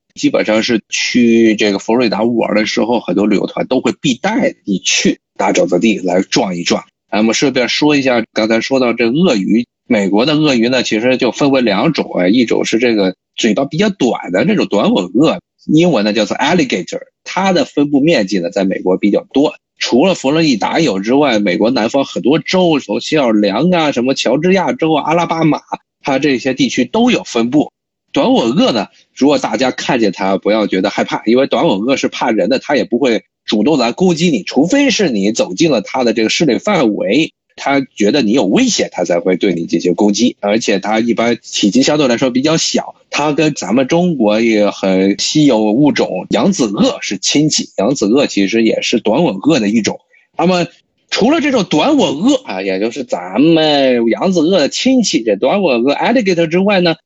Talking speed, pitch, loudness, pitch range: 310 characters per minute, 135 Hz, -13 LUFS, 110-175 Hz